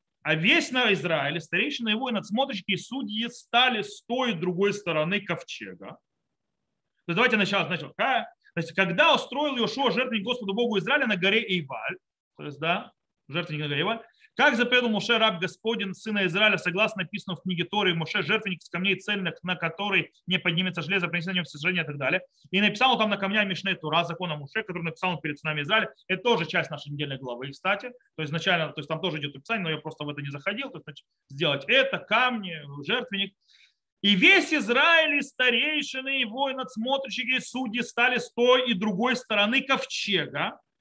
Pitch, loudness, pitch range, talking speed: 200 Hz, -25 LUFS, 170-245 Hz, 190 wpm